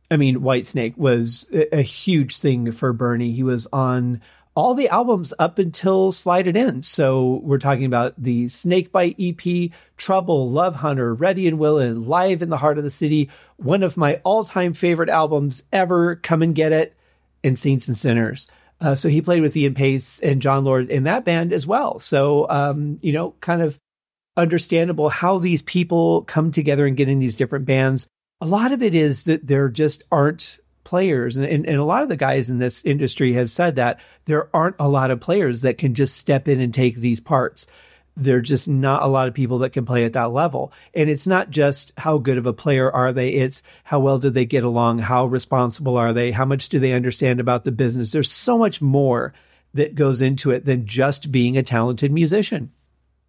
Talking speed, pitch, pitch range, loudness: 210 wpm, 140 Hz, 130-165 Hz, -19 LUFS